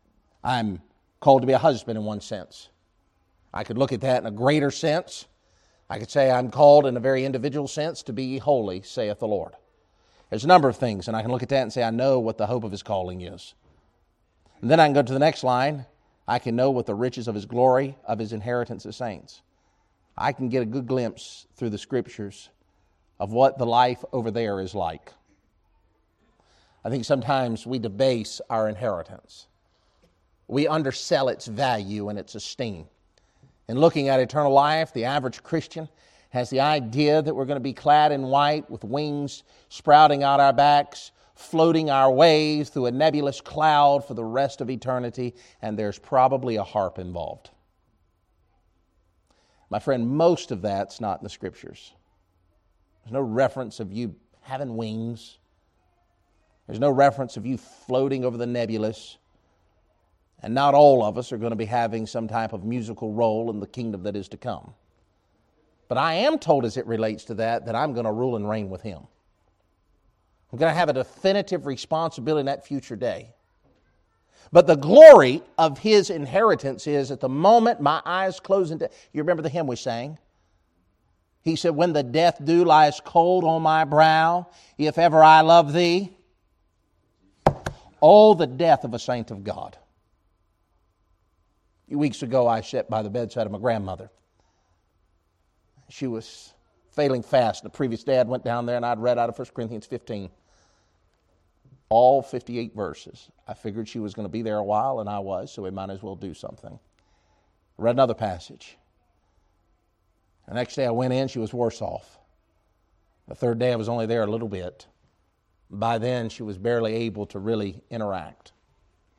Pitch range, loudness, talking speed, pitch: 95-135 Hz, -22 LUFS, 180 wpm, 115 Hz